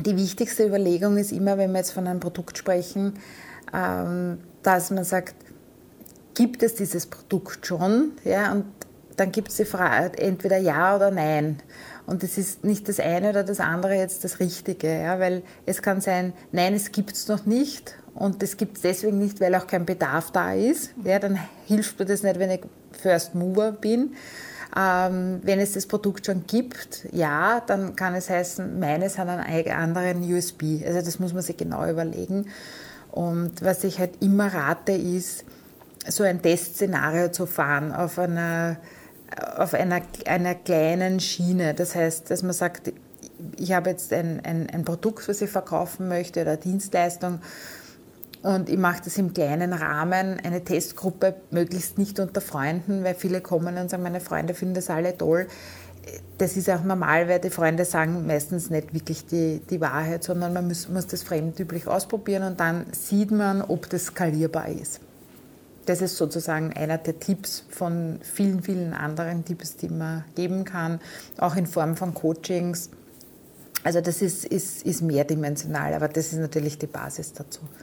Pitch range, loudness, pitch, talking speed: 170-195 Hz, -25 LUFS, 180 Hz, 170 wpm